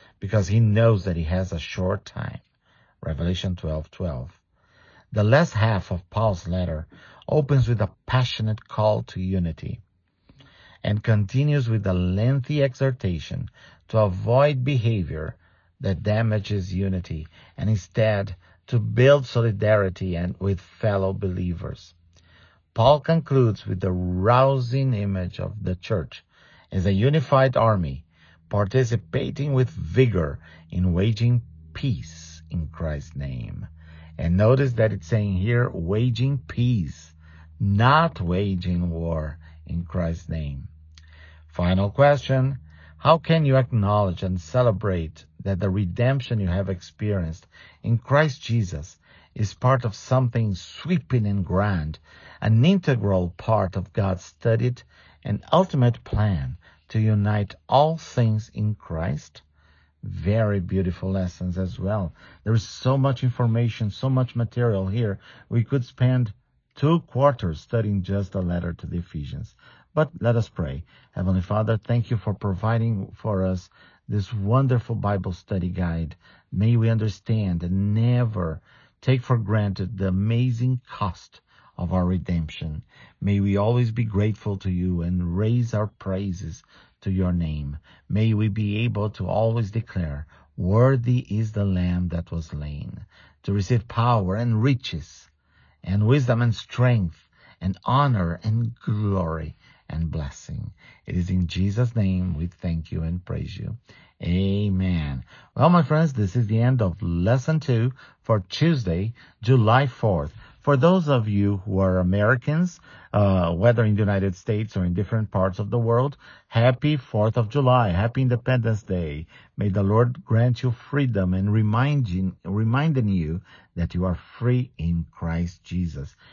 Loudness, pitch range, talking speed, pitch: -23 LUFS, 90-120 Hz, 140 wpm, 100 Hz